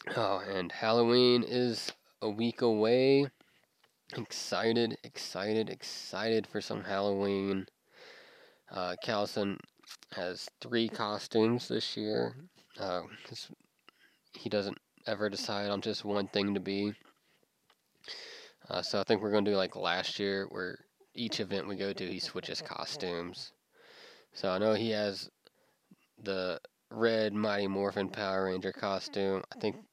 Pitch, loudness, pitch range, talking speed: 105 Hz, -33 LUFS, 100-115 Hz, 130 wpm